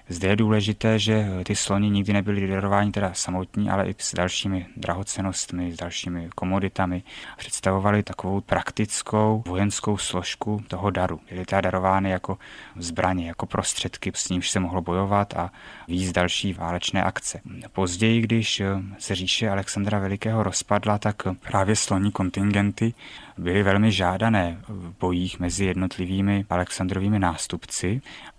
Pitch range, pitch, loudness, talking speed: 90-105 Hz, 95 Hz, -24 LUFS, 135 wpm